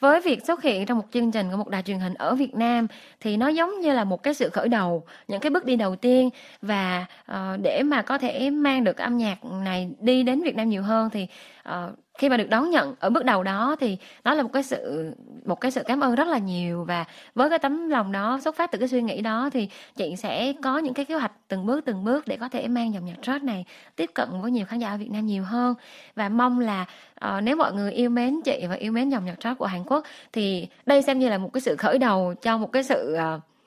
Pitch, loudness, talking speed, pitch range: 245 Hz, -25 LUFS, 275 wpm, 200-275 Hz